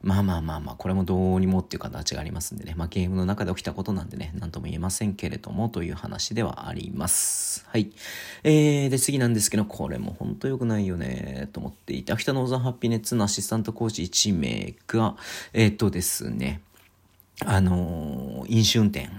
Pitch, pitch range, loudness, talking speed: 100 Hz, 90-110 Hz, -26 LUFS, 420 characters per minute